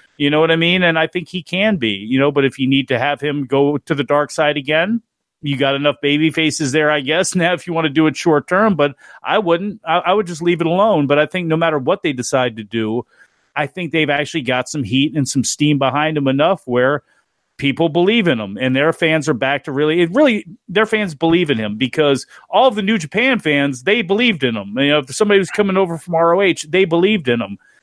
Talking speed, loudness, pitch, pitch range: 255 wpm, -16 LUFS, 155 Hz, 140-175 Hz